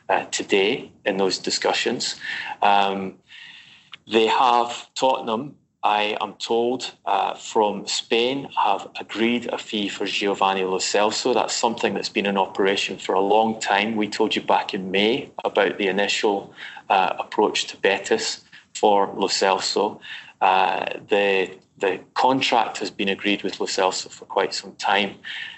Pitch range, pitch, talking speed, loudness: 100-120 Hz, 110 Hz, 145 wpm, -22 LUFS